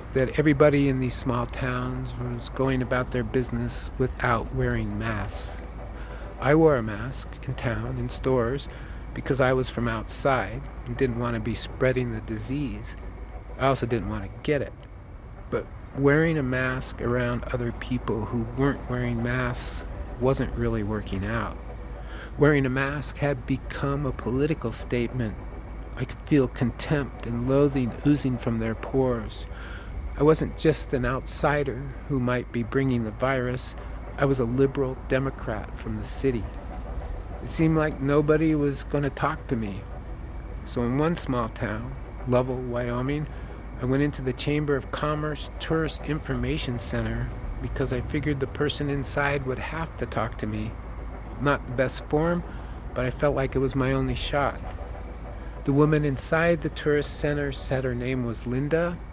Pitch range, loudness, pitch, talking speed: 115-140 Hz, -26 LUFS, 125 Hz, 160 wpm